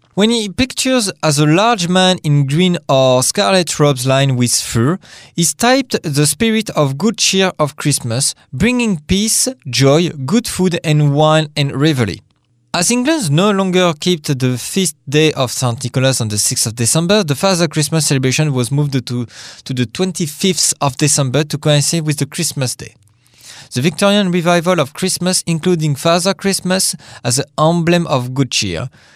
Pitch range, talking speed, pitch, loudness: 135-185 Hz, 165 wpm, 155 Hz, -14 LUFS